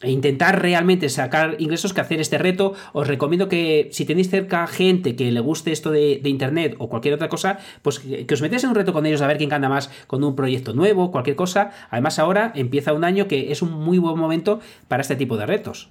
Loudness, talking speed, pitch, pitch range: -20 LUFS, 240 wpm, 155 Hz, 145-185 Hz